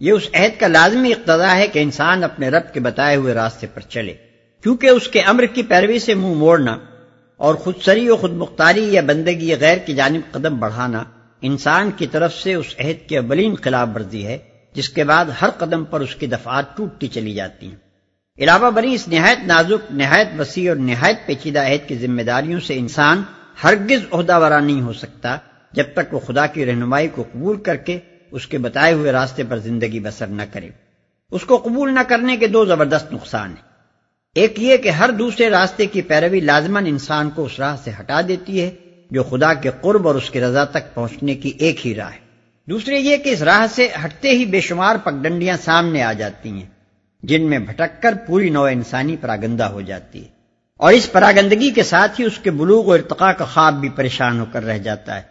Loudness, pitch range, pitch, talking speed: -16 LUFS, 125-185 Hz, 155 Hz, 210 wpm